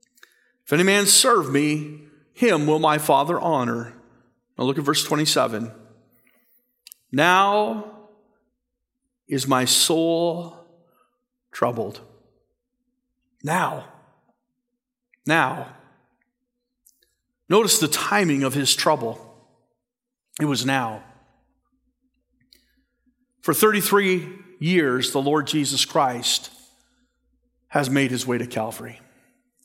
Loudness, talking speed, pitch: -20 LUFS, 90 wpm, 175 Hz